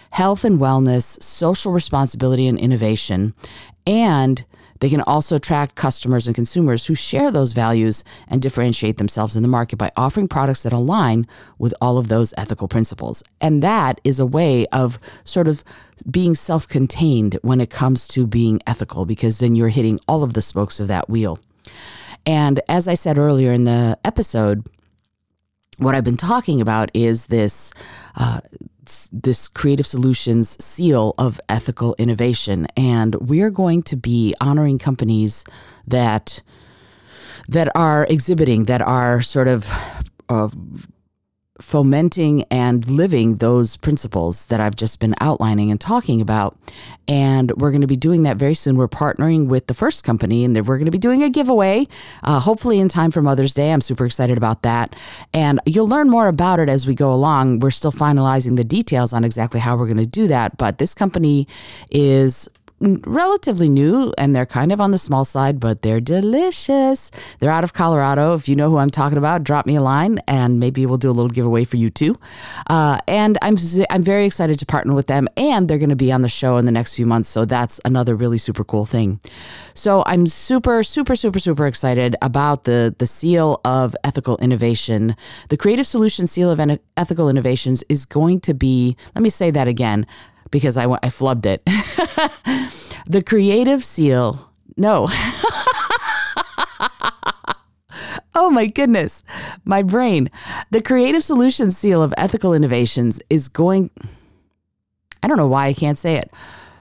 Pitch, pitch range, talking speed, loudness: 135 Hz, 115-165 Hz, 175 wpm, -17 LUFS